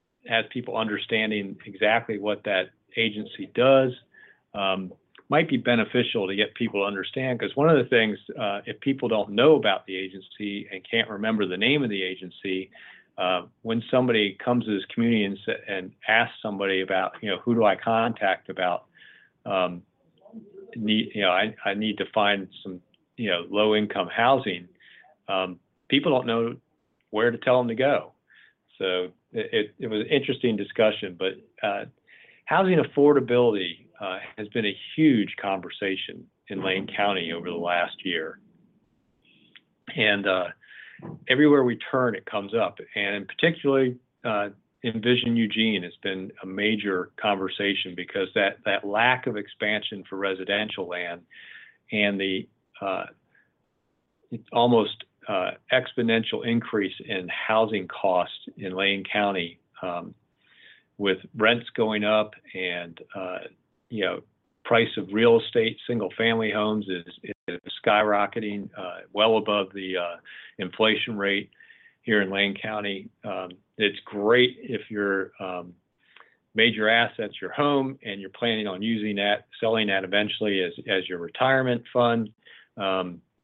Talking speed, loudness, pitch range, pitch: 145 wpm, -25 LUFS, 95-115 Hz, 105 Hz